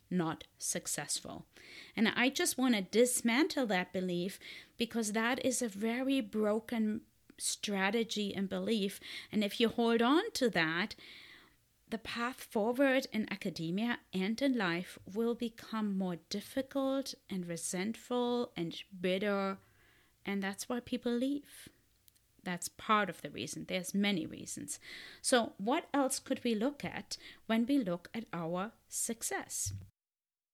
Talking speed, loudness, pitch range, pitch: 135 wpm, -35 LUFS, 190-245 Hz, 225 Hz